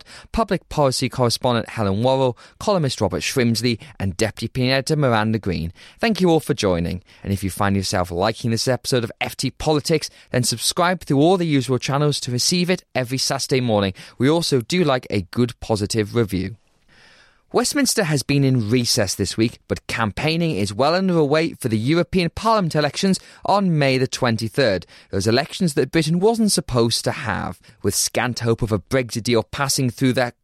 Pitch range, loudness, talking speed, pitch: 115-155 Hz, -20 LUFS, 175 wpm, 130 Hz